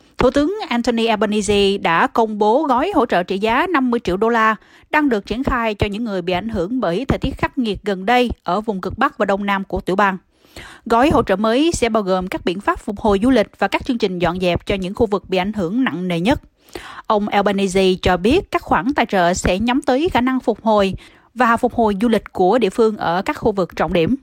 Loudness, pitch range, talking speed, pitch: -18 LUFS, 195-245 Hz, 255 wpm, 220 Hz